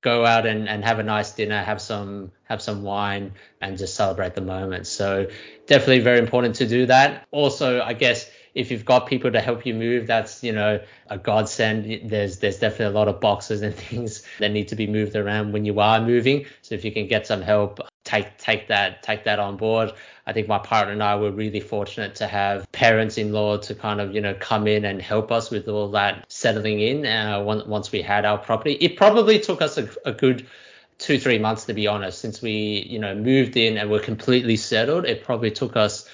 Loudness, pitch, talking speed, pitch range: -22 LUFS, 110 Hz, 225 wpm, 105-115 Hz